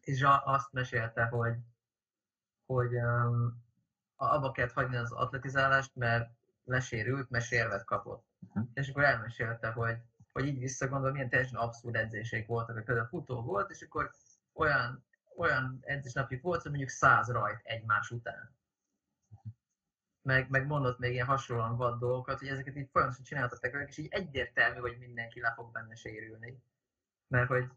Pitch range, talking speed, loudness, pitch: 115-135 Hz, 150 wpm, -33 LUFS, 125 Hz